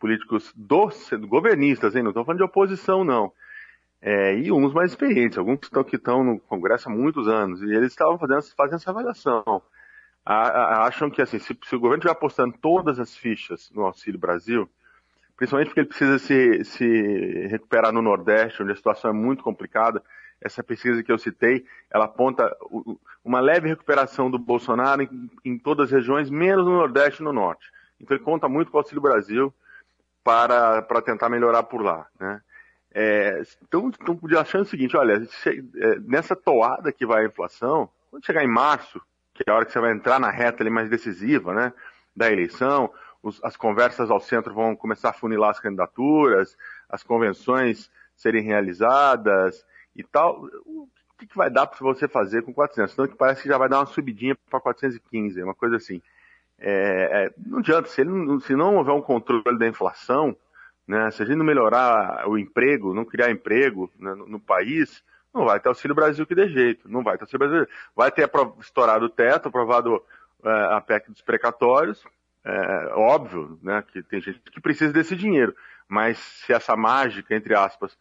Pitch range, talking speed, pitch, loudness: 115-160 Hz, 190 wpm, 130 Hz, -22 LUFS